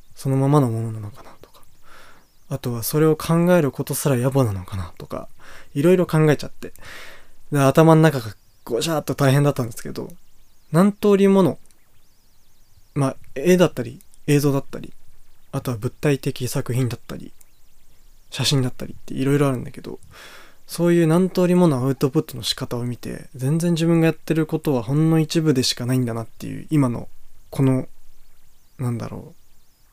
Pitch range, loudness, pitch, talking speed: 115-155 Hz, -20 LUFS, 135 Hz, 345 characters per minute